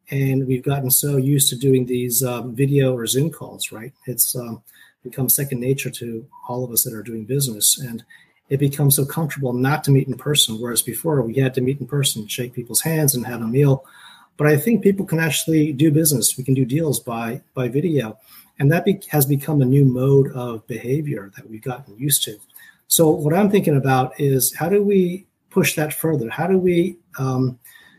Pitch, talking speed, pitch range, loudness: 135 Hz, 210 wpm, 125-150 Hz, -19 LUFS